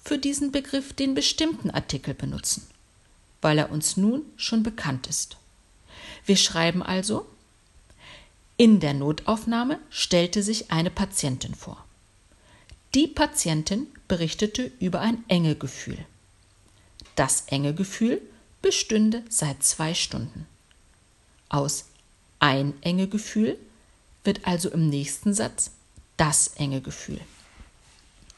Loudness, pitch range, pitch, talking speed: -25 LUFS, 130-220 Hz, 165 Hz, 110 wpm